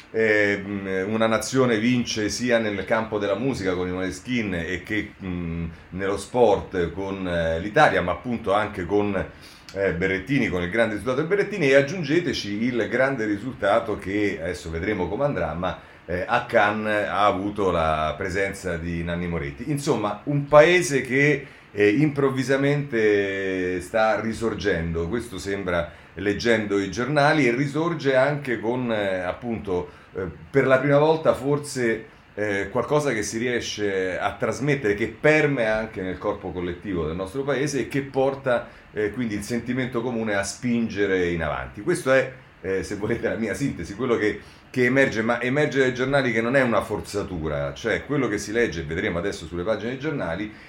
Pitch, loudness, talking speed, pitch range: 105 Hz, -23 LUFS, 160 wpm, 95-130 Hz